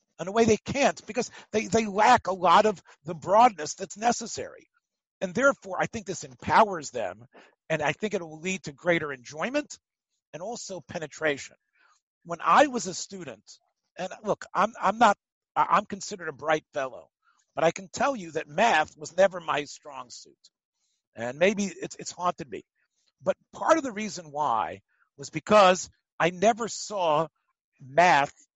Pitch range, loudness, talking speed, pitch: 160-220 Hz, -26 LUFS, 170 wpm, 190 Hz